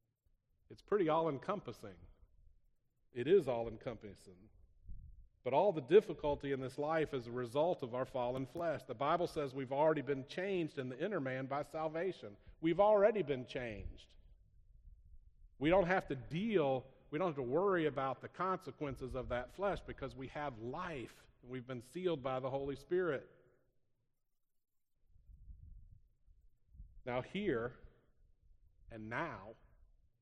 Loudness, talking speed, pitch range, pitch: -38 LUFS, 140 wpm, 100-150 Hz, 130 Hz